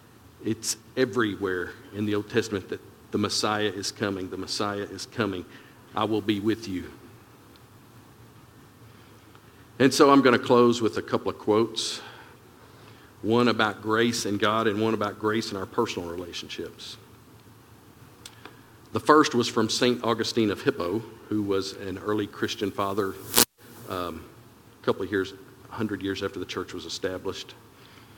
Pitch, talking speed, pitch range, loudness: 110 Hz, 150 wpm, 105-120 Hz, -26 LUFS